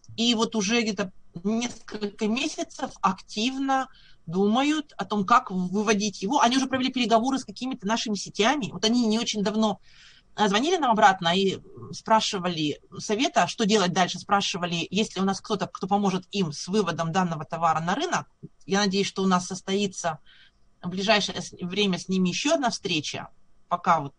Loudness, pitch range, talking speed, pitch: -25 LUFS, 180-225 Hz, 165 wpm, 200 Hz